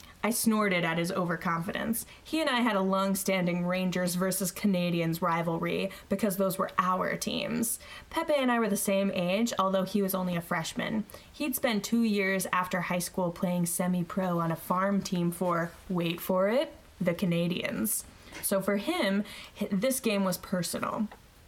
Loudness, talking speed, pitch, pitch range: -29 LUFS, 170 wpm, 190 Hz, 180-210 Hz